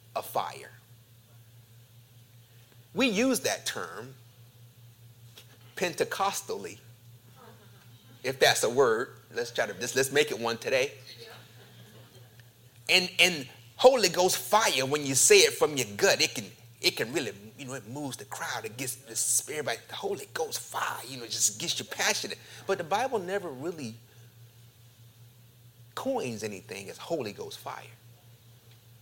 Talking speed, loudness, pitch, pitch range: 145 wpm, -27 LUFS, 120 Hz, 115-145 Hz